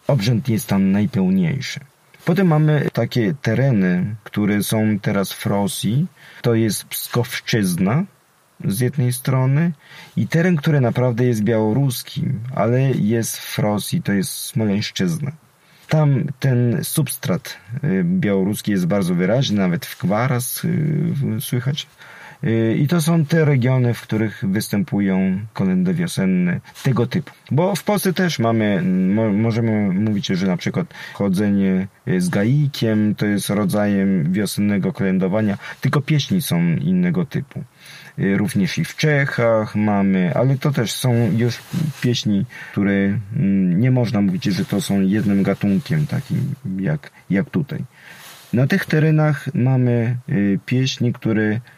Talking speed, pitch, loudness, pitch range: 125 wpm, 130 Hz, -19 LUFS, 110-160 Hz